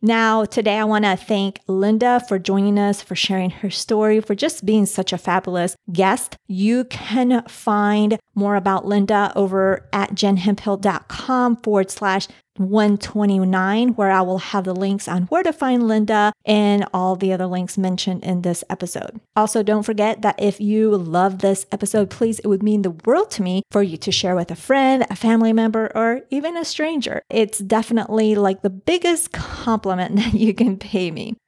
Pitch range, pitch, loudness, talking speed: 190-220 Hz, 205 Hz, -19 LUFS, 180 wpm